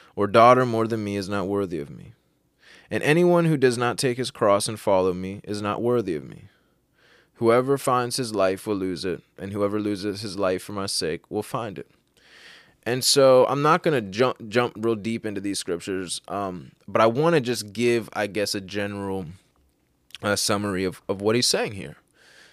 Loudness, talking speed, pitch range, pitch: -23 LUFS, 200 wpm, 100-120 Hz, 105 Hz